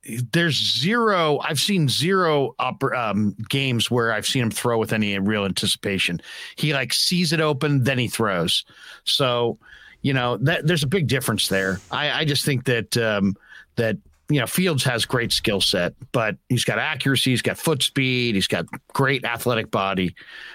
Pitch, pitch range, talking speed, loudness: 125 Hz, 110-150 Hz, 180 wpm, -21 LUFS